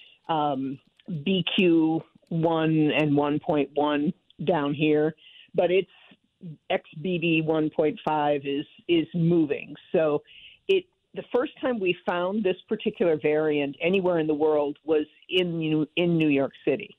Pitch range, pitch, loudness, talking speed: 150-180 Hz, 160 Hz, -25 LUFS, 125 wpm